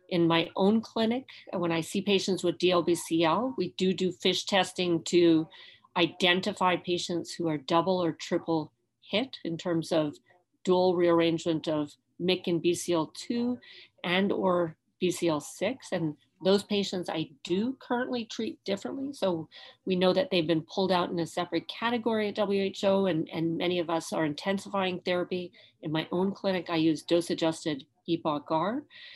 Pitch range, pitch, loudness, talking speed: 165-195 Hz, 175 Hz, -29 LUFS, 150 wpm